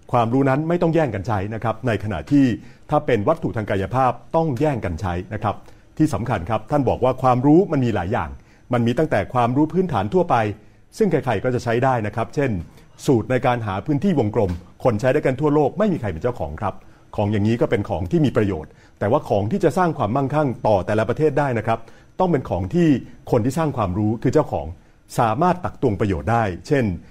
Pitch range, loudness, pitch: 105-150 Hz, -21 LUFS, 120 Hz